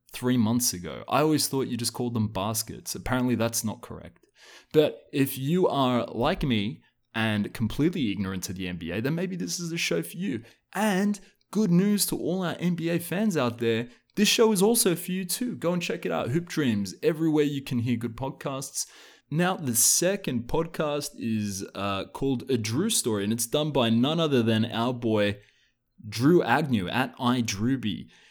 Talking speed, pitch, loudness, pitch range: 185 wpm, 130 Hz, -26 LUFS, 115-170 Hz